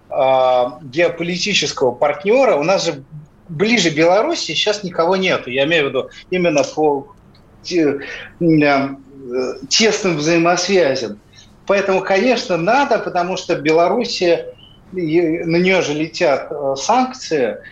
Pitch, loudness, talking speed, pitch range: 170 Hz, -16 LUFS, 100 wpm, 145-190 Hz